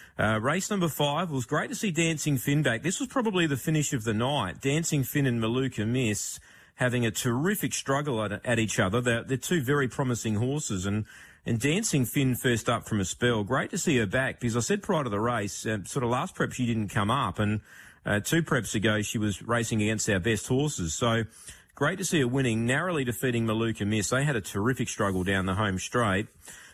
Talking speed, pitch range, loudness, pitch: 225 wpm, 110-145 Hz, -27 LUFS, 125 Hz